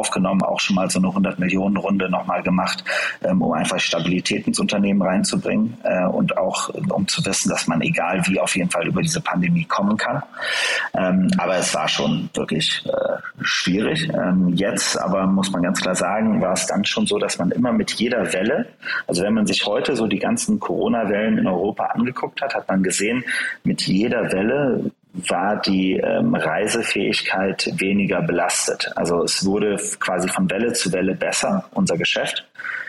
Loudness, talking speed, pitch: -20 LUFS, 170 wpm, 100 Hz